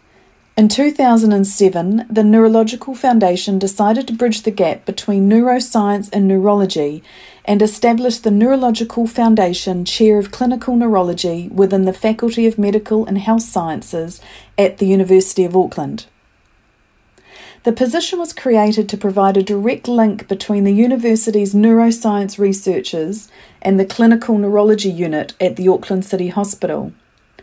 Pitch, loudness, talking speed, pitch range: 210 Hz, -15 LUFS, 130 wpm, 195-230 Hz